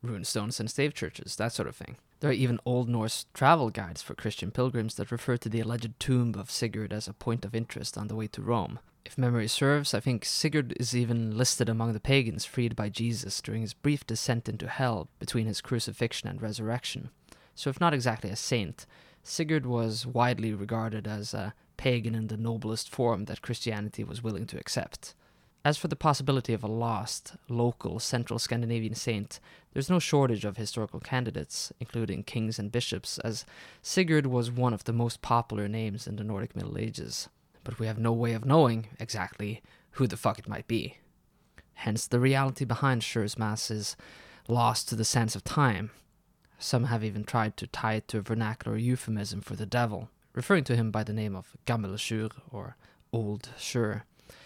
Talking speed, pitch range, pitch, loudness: 190 wpm, 110-125 Hz, 115 Hz, -30 LUFS